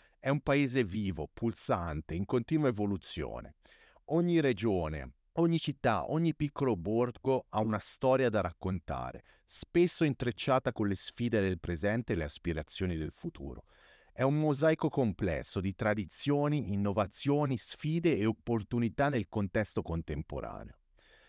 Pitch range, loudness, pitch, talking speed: 95-140 Hz, -33 LUFS, 115 Hz, 125 wpm